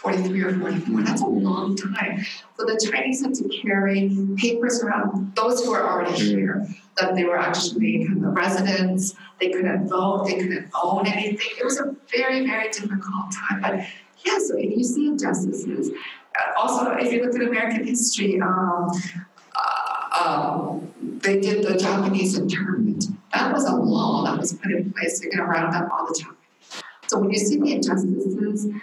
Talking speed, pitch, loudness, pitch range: 180 wpm, 200 Hz, -23 LUFS, 185-225 Hz